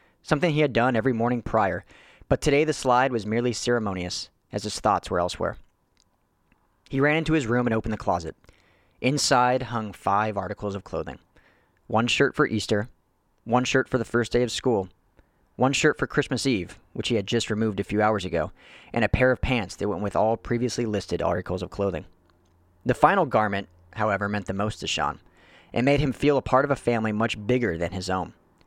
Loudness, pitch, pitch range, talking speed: -25 LUFS, 110 Hz, 100-130 Hz, 205 wpm